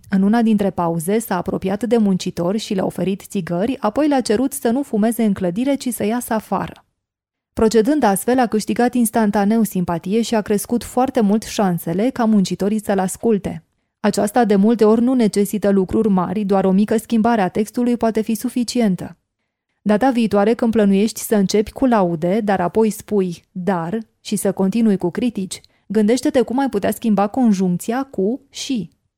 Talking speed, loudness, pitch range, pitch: 170 wpm, -18 LUFS, 195-235 Hz, 215 Hz